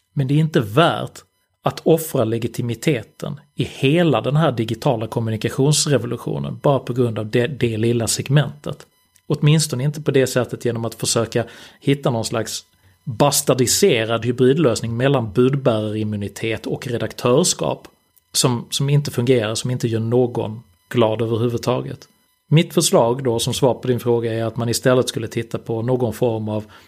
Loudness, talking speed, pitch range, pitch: -19 LUFS, 150 wpm, 115-140 Hz, 125 Hz